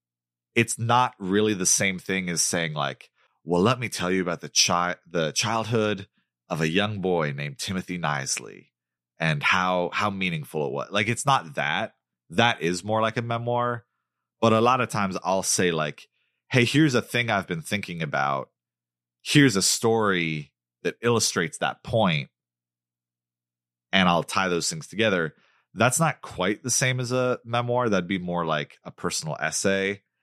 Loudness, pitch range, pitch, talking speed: -24 LUFS, 75-115 Hz, 95 Hz, 170 wpm